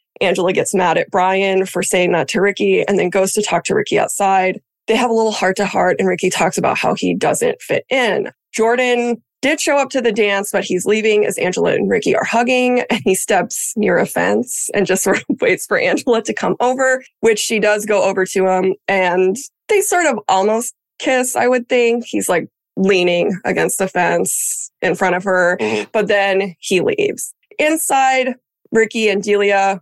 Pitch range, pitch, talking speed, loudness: 190-245 Hz, 210 Hz, 200 wpm, -16 LUFS